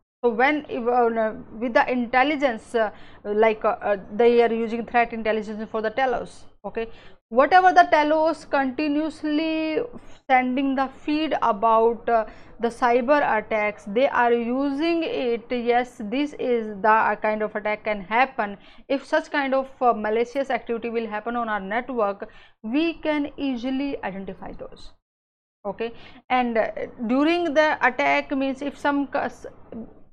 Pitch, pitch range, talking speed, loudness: 240 Hz, 220-275 Hz, 125 wpm, -23 LUFS